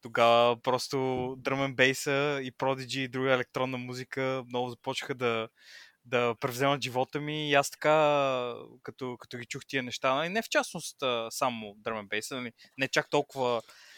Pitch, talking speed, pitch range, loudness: 130 Hz, 155 wpm, 125-140 Hz, -30 LUFS